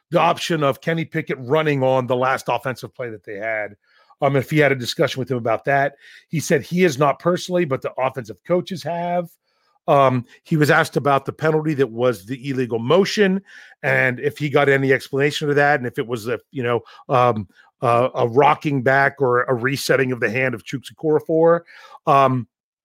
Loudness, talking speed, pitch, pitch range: -19 LUFS, 200 wpm, 140 Hz, 130-160 Hz